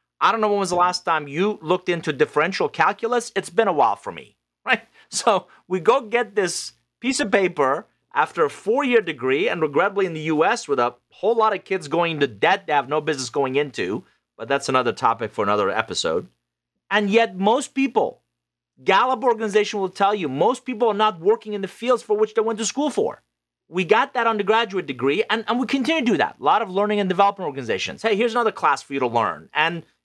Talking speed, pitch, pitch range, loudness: 225 wpm, 200 Hz, 155-230 Hz, -21 LUFS